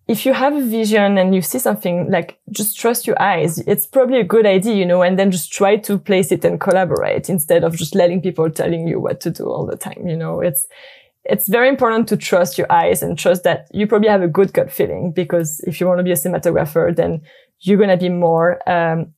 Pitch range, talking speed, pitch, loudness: 175-210 Hz, 245 wpm, 185 Hz, -16 LUFS